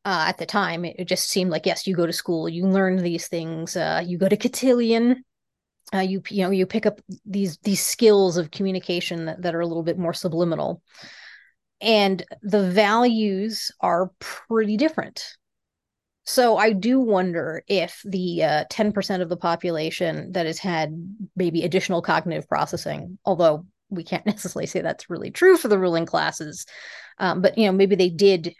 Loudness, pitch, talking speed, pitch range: -22 LUFS, 185 Hz, 180 wpm, 170-205 Hz